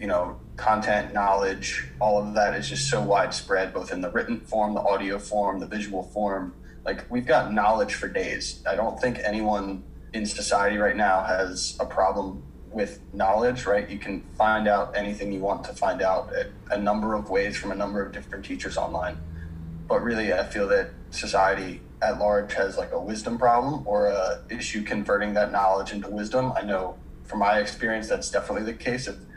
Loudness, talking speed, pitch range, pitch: -26 LUFS, 190 wpm, 95-105 Hz, 100 Hz